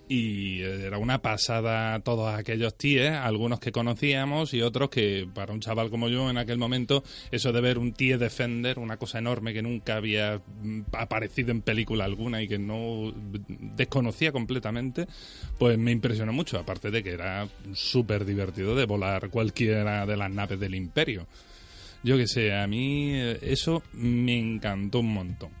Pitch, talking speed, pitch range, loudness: 115 Hz, 165 wpm, 105-125 Hz, -28 LUFS